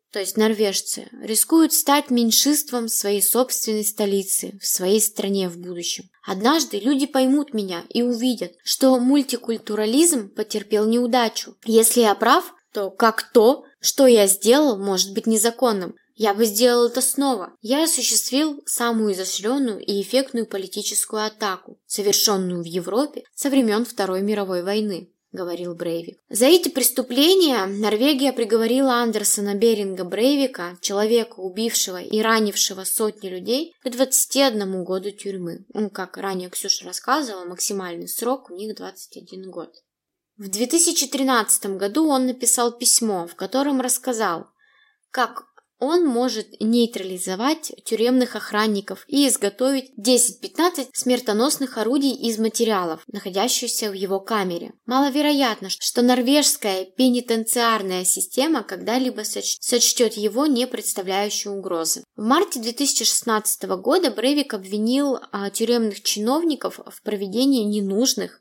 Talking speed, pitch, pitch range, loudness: 120 wpm, 225 Hz, 200-260 Hz, -20 LUFS